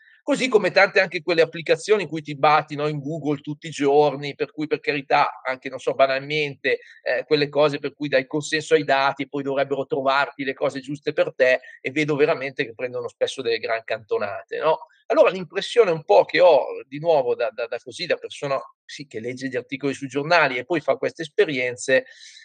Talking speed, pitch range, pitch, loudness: 210 wpm, 140-215 Hz, 150 Hz, -22 LUFS